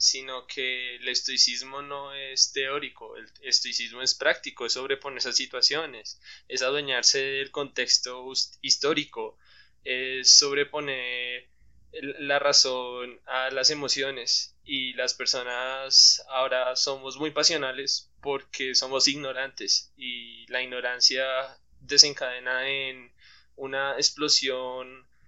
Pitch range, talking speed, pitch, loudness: 125-140 Hz, 110 wpm, 130 Hz, -24 LUFS